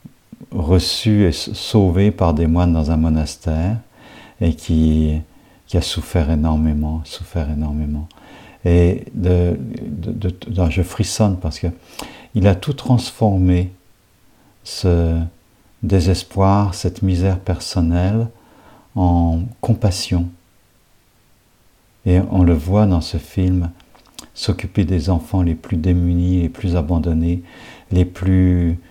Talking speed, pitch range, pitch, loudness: 110 wpm, 85-100 Hz, 90 Hz, -18 LUFS